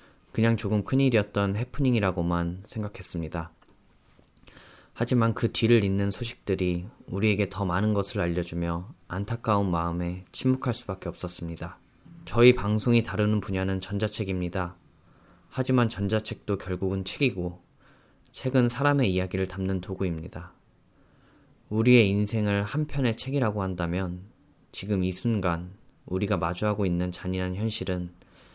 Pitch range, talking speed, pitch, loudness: 90-115 Hz, 310 characters per minute, 100 Hz, -27 LUFS